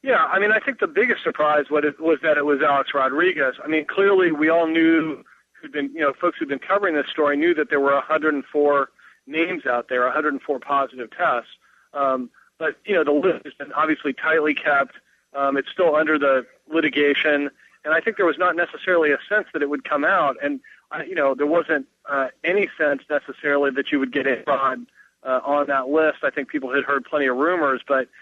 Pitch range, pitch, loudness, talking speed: 140-165 Hz, 150 Hz, -21 LUFS, 215 wpm